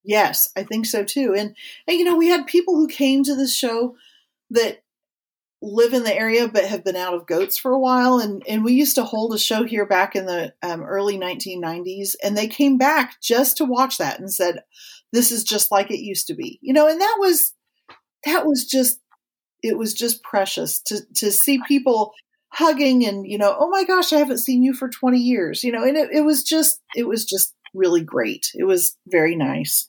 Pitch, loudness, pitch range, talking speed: 245 Hz, -19 LUFS, 205-295 Hz, 220 wpm